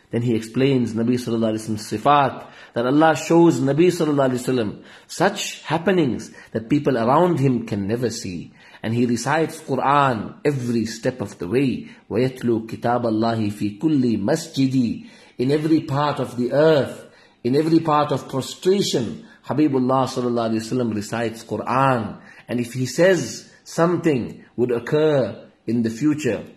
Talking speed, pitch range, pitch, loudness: 145 wpm, 115-150 Hz, 130 Hz, -21 LUFS